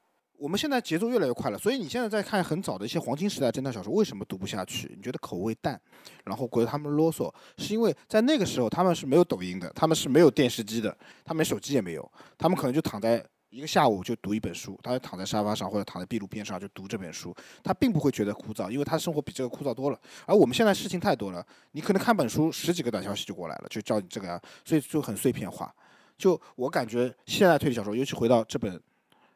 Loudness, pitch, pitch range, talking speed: -28 LUFS, 135 Hz, 110-170 Hz, 405 characters per minute